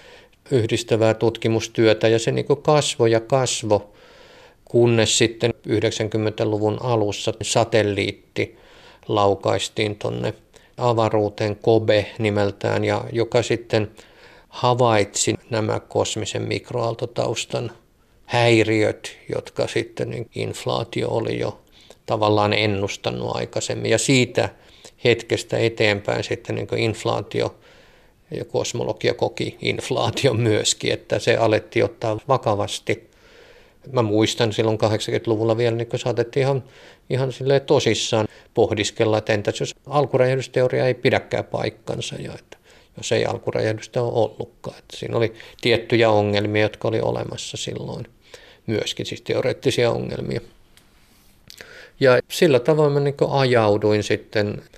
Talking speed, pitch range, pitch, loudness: 110 wpm, 105-120 Hz, 115 Hz, -21 LUFS